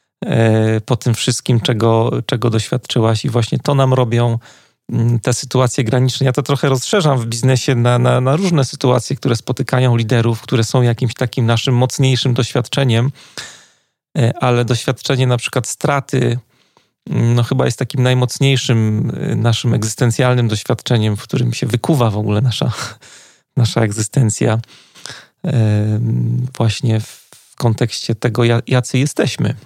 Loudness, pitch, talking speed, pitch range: -16 LUFS, 125 Hz, 125 wpm, 115-130 Hz